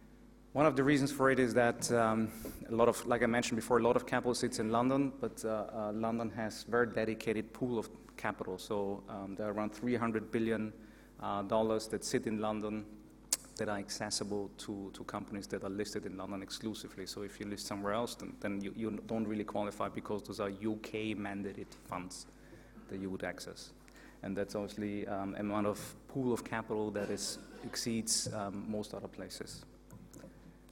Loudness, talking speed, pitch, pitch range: -36 LUFS, 190 wpm, 105 Hz, 100-115 Hz